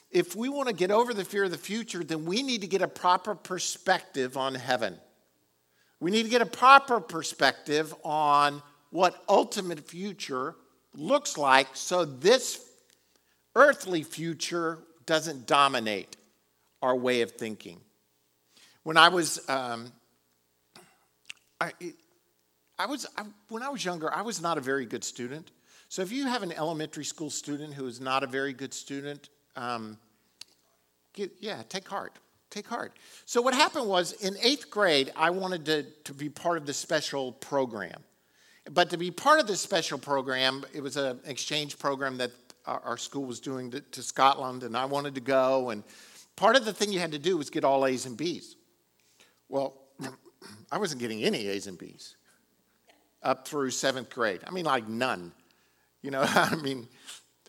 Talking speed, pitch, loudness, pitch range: 170 wpm, 145 Hz, -28 LUFS, 130-180 Hz